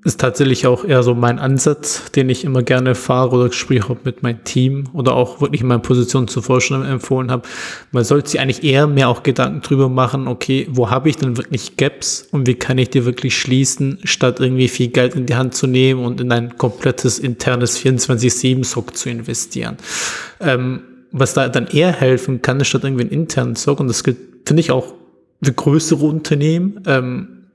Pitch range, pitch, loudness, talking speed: 125-135 Hz, 130 Hz, -16 LUFS, 200 wpm